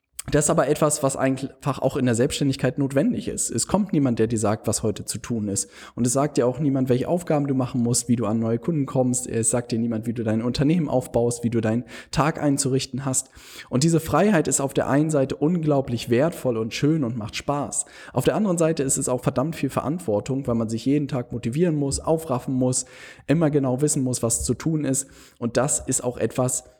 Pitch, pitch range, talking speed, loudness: 130 Hz, 120-145 Hz, 230 wpm, -23 LUFS